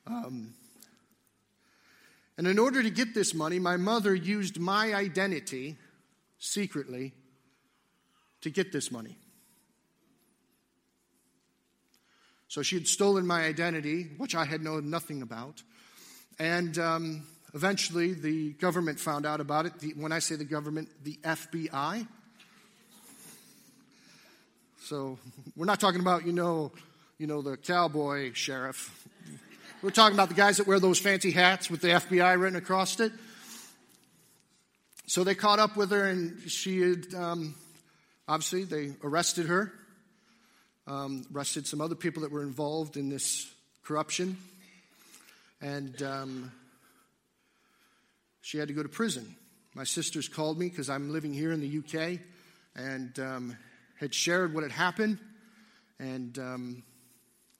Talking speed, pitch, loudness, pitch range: 135 wpm, 165 Hz, -30 LUFS, 145-190 Hz